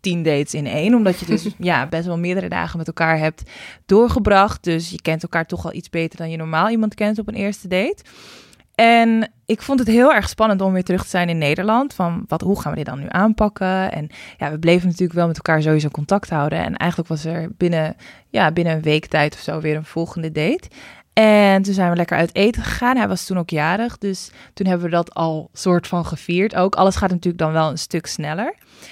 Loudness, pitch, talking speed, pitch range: -19 LUFS, 175 Hz, 235 wpm, 160-200 Hz